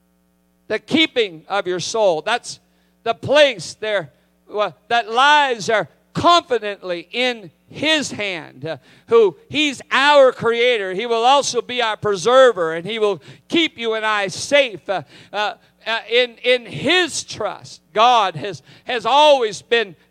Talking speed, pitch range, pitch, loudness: 140 wpm, 195-275 Hz, 230 Hz, -17 LUFS